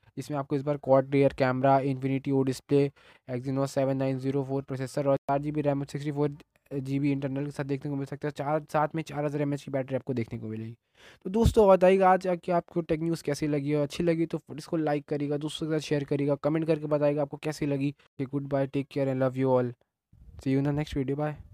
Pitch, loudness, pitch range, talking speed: 145 Hz, -28 LUFS, 135-150 Hz, 250 wpm